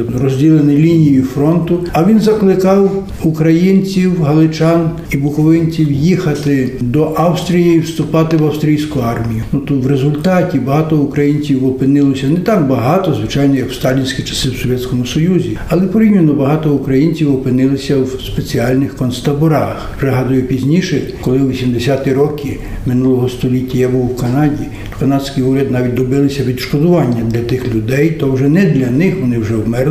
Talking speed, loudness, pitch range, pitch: 145 wpm, -13 LUFS, 130-160 Hz, 140 Hz